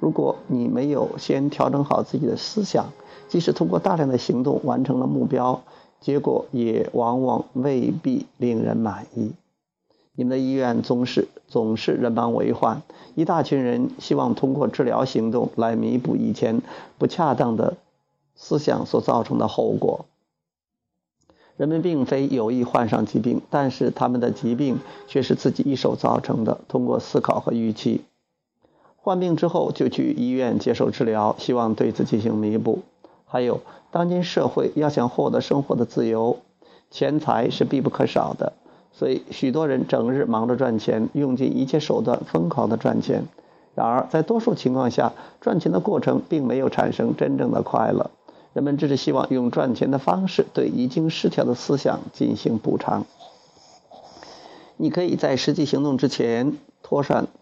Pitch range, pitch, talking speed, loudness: 120-155 Hz, 135 Hz, 250 characters per minute, -22 LUFS